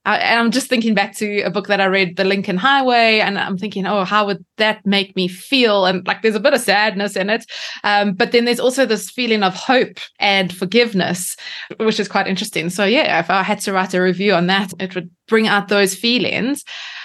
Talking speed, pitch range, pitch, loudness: 230 wpm, 190-225 Hz, 205 Hz, -16 LUFS